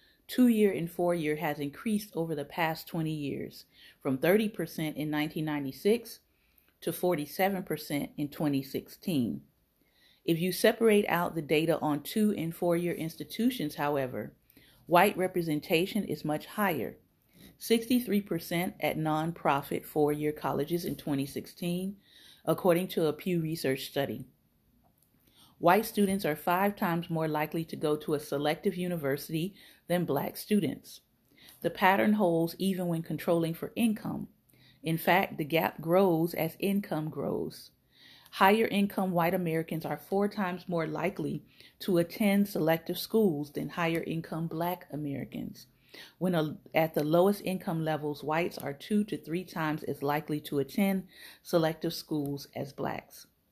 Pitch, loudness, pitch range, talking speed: 165 Hz, -31 LUFS, 150-190 Hz, 140 wpm